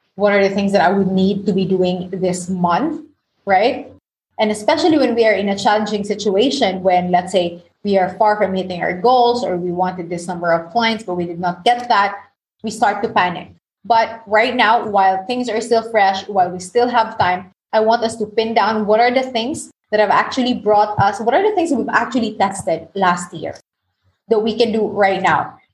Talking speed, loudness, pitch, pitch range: 220 wpm, -17 LUFS, 205 Hz, 185-230 Hz